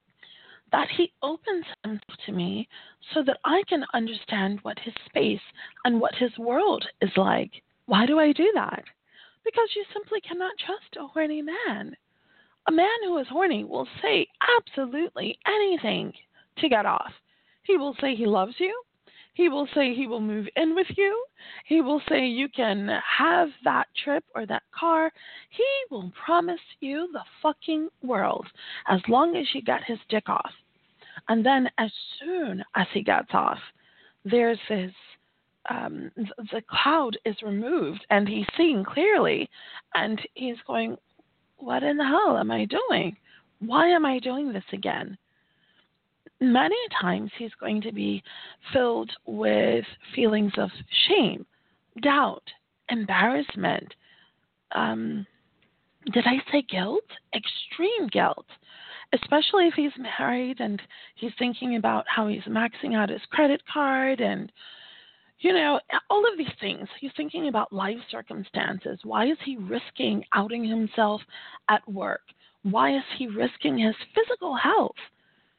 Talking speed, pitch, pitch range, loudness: 145 wpm, 270 Hz, 220-335 Hz, -26 LUFS